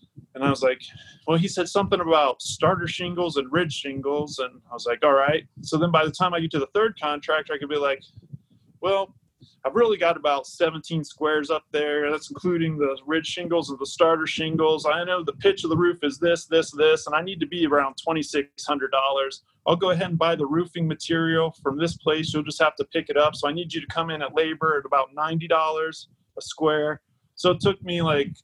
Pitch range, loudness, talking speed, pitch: 145-170 Hz, -24 LUFS, 230 wpm, 155 Hz